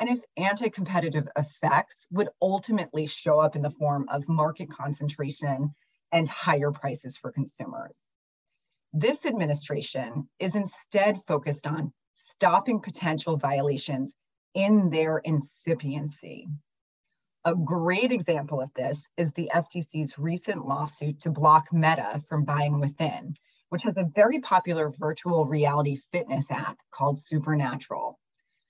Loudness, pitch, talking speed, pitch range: -27 LUFS, 155 Hz, 125 wpm, 145-175 Hz